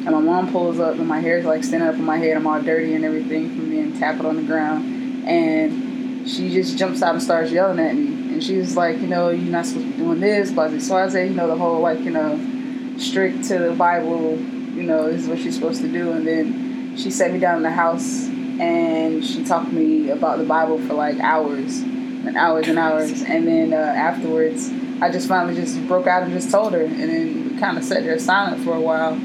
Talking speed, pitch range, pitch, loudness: 250 wpm, 255-295 Hz, 260 Hz, -20 LUFS